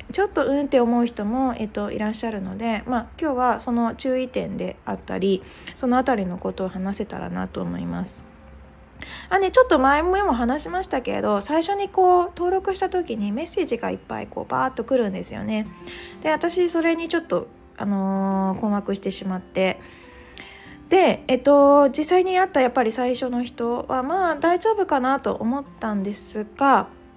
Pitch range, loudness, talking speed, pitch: 205-325 Hz, -22 LUFS, 355 characters per minute, 250 Hz